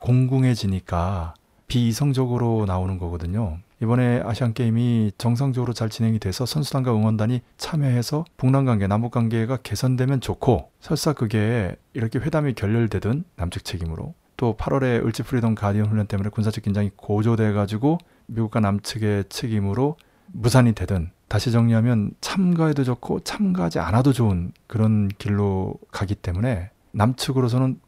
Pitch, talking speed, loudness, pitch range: 115 Hz, 355 characters per minute, -23 LUFS, 105-130 Hz